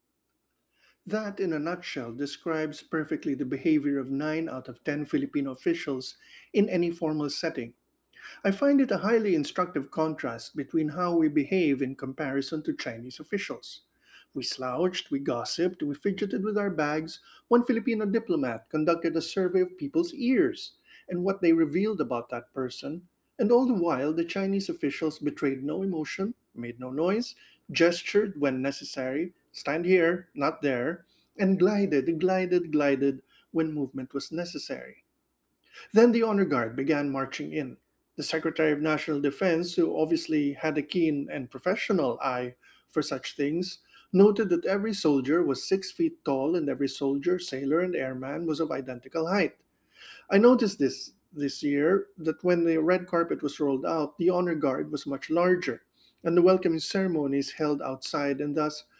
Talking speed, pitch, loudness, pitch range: 160 wpm, 165 Hz, -28 LUFS, 145-190 Hz